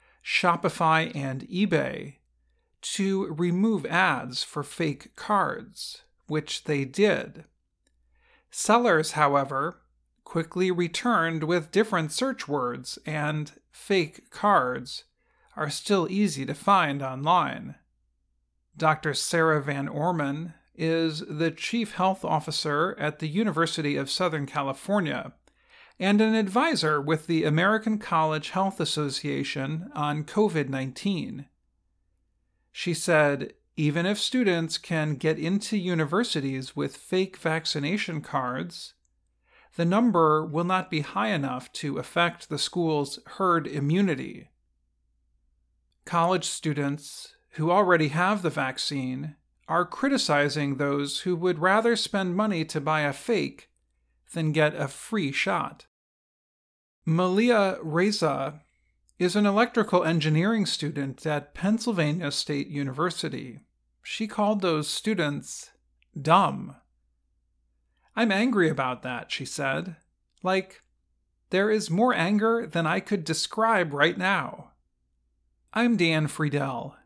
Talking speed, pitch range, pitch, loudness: 110 wpm, 140-190 Hz, 160 Hz, -26 LUFS